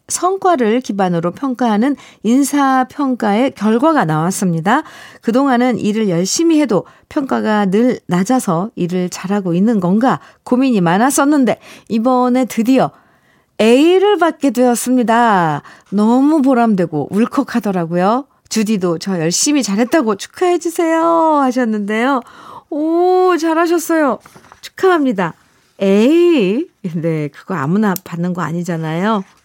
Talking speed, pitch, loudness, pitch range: 280 characters per minute, 235 Hz, -14 LUFS, 195-280 Hz